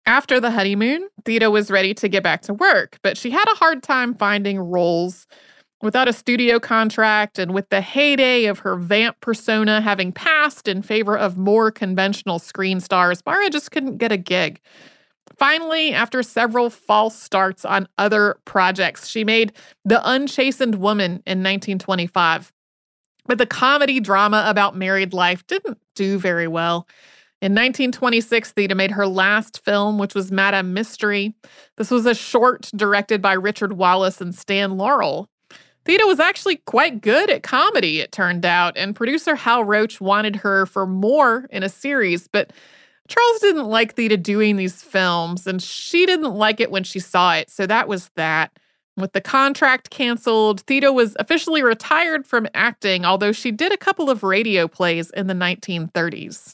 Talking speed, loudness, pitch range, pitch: 165 wpm, -18 LUFS, 190-250 Hz, 210 Hz